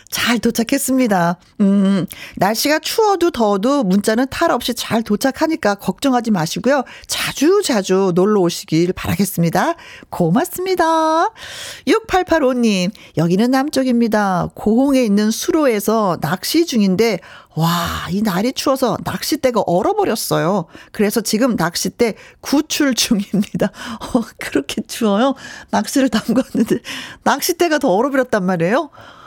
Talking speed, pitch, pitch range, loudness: 285 characters per minute, 235 Hz, 200-275 Hz, -17 LUFS